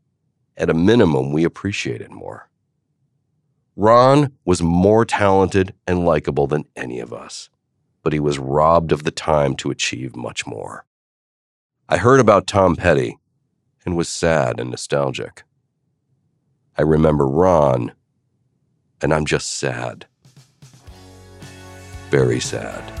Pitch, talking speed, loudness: 95 Hz, 125 wpm, -18 LUFS